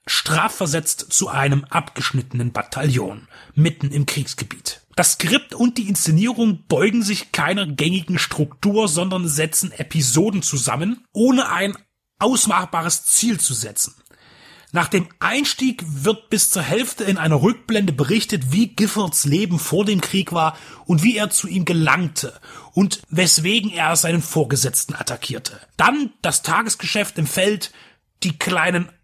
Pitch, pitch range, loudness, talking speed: 175 Hz, 150-205 Hz, -19 LUFS, 135 wpm